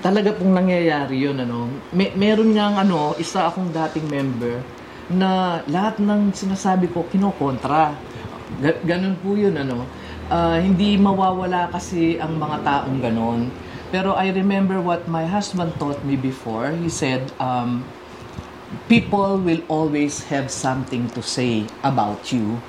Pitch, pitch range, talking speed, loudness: 165 Hz, 130-190 Hz, 140 wpm, -21 LUFS